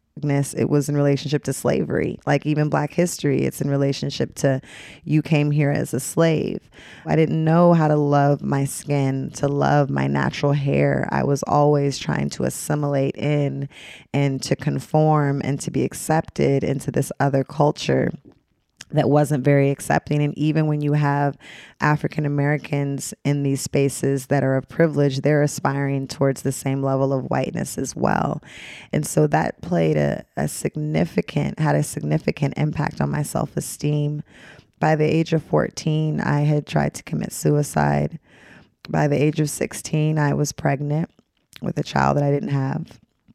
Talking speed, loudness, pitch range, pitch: 165 wpm, -21 LUFS, 135-150 Hz, 145 Hz